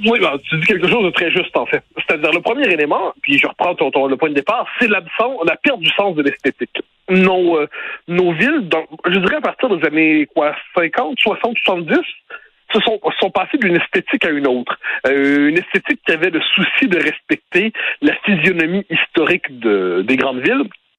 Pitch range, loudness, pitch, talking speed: 160-225 Hz, -15 LUFS, 180 Hz, 210 wpm